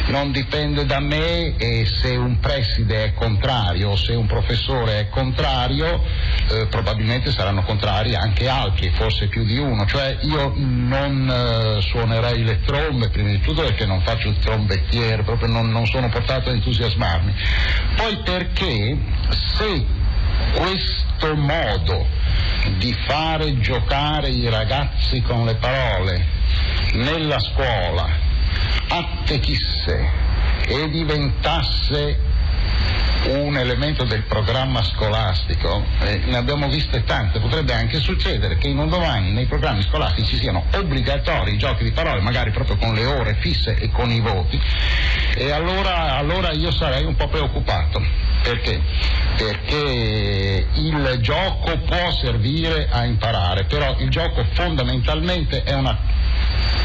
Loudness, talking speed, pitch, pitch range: -20 LUFS, 130 wpm, 110 Hz, 90-125 Hz